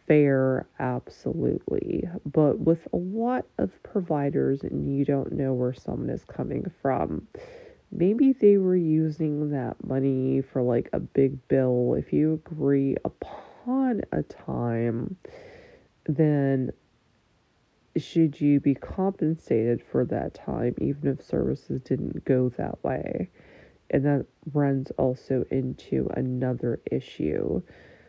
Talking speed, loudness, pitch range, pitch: 120 wpm, -26 LUFS, 130-165 Hz, 140 Hz